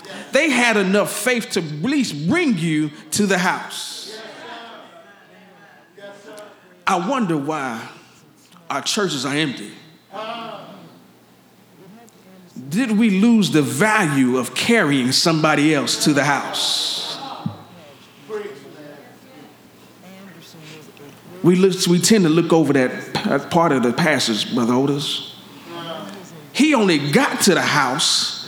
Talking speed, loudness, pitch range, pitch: 105 wpm, -18 LUFS, 150-215 Hz, 185 Hz